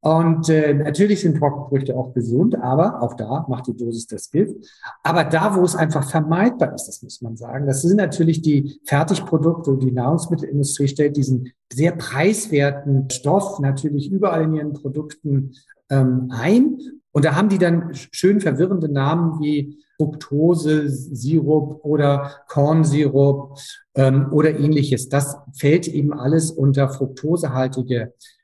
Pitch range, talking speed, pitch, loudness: 135-165 Hz, 145 wpm, 150 Hz, -19 LUFS